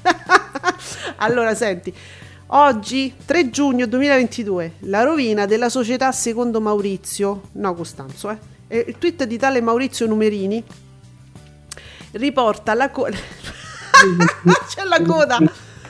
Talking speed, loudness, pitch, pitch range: 100 wpm, -18 LUFS, 225 Hz, 190-265 Hz